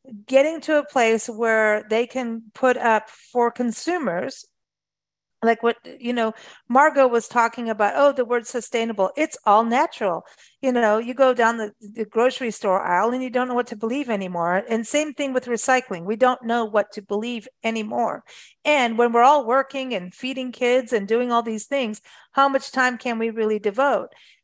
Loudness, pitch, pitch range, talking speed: -21 LUFS, 235 Hz, 225-260 Hz, 185 wpm